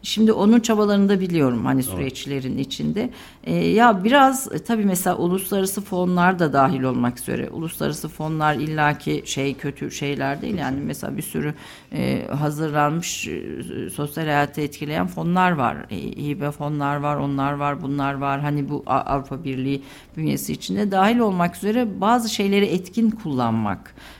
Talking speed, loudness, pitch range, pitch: 140 wpm, -22 LUFS, 140-195 Hz, 150 Hz